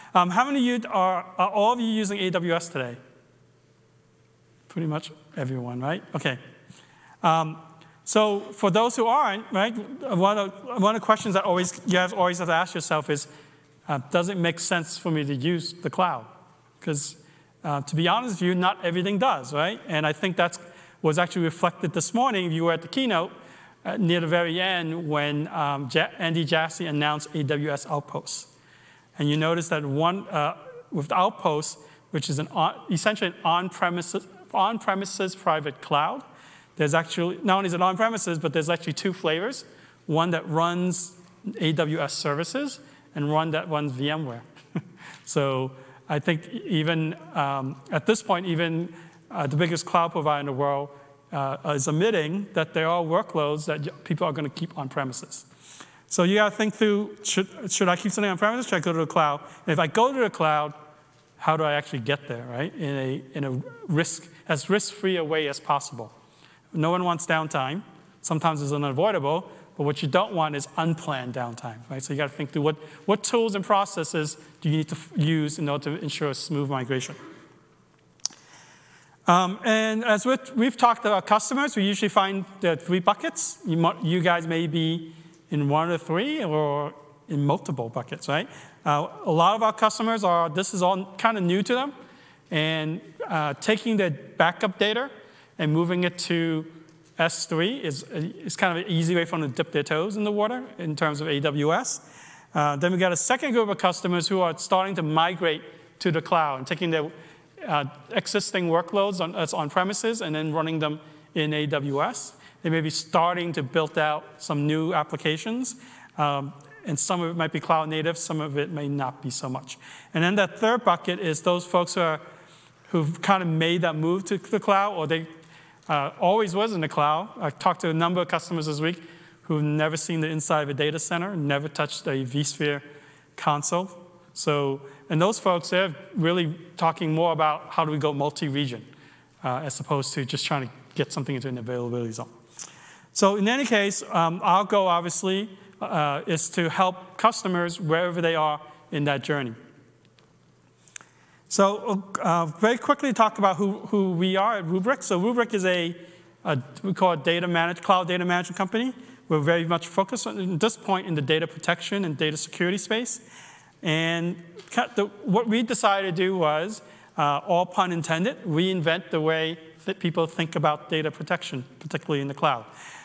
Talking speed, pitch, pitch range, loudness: 185 wpm, 165 Hz, 150-190 Hz, -25 LUFS